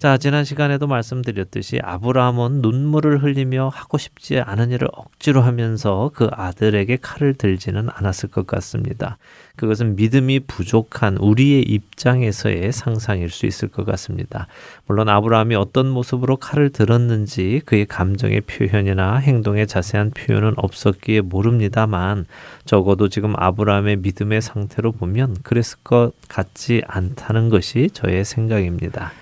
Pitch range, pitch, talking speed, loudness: 100-125 Hz, 110 Hz, 340 characters per minute, -19 LUFS